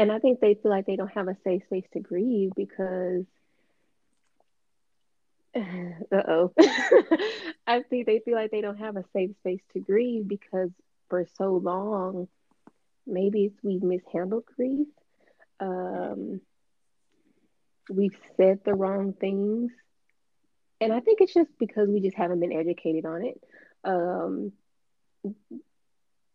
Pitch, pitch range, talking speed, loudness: 200 Hz, 185-235 Hz, 130 wpm, -27 LUFS